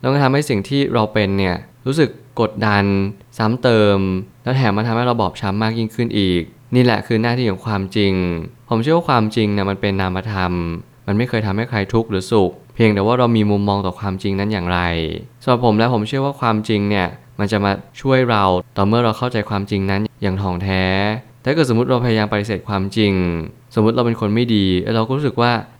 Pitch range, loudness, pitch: 100-120 Hz, -18 LUFS, 110 Hz